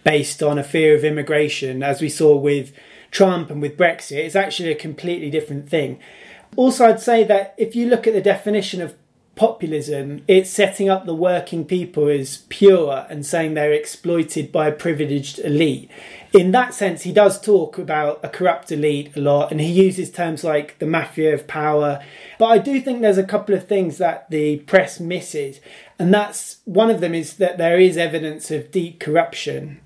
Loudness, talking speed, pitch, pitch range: -18 LUFS, 190 wpm, 165 Hz, 150-195 Hz